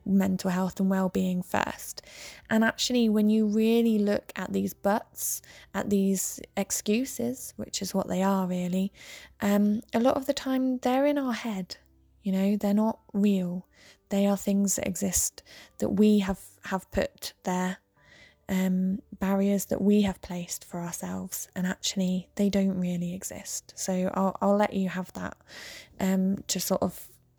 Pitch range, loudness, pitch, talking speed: 185-210 Hz, -28 LUFS, 195 Hz, 160 wpm